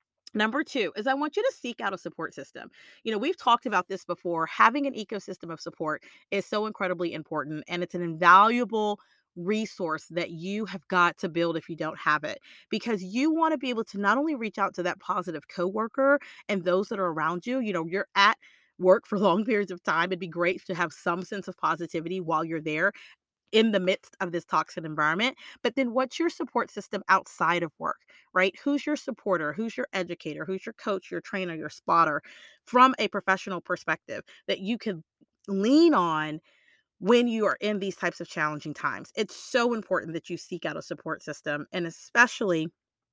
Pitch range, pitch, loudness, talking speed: 170-225 Hz, 190 Hz, -27 LUFS, 205 wpm